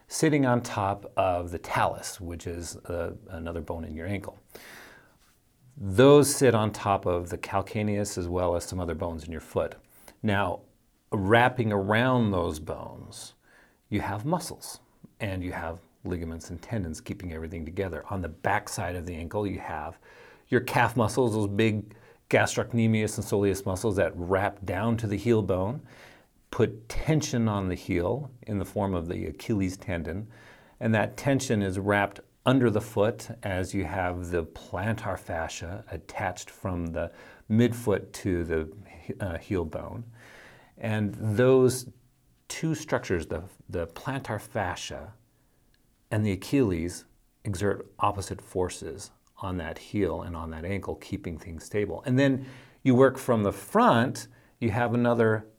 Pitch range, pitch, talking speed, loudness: 90-115 Hz, 100 Hz, 150 wpm, -28 LUFS